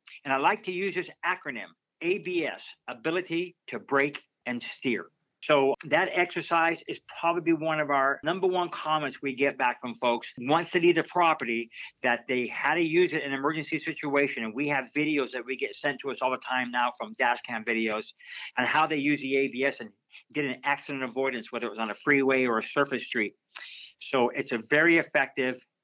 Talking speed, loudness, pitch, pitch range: 200 wpm, -28 LUFS, 140 Hz, 125-160 Hz